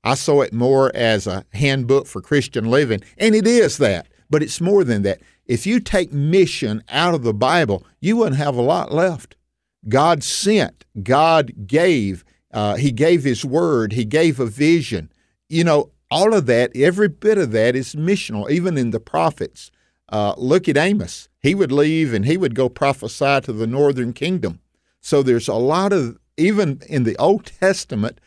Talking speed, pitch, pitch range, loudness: 185 wpm, 140 Hz, 115-165 Hz, -18 LUFS